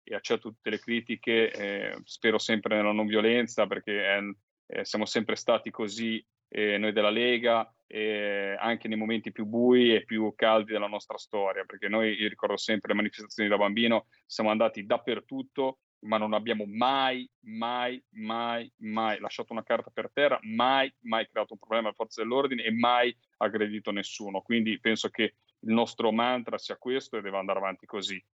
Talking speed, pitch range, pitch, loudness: 175 wpm, 105-115 Hz, 110 Hz, -29 LUFS